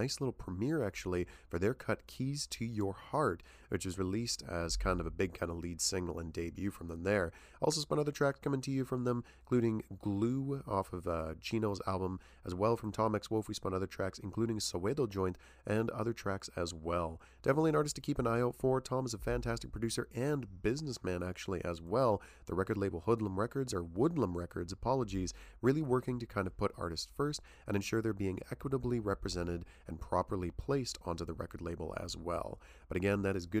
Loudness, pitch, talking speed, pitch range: -37 LUFS, 100 Hz, 210 wpm, 90-120 Hz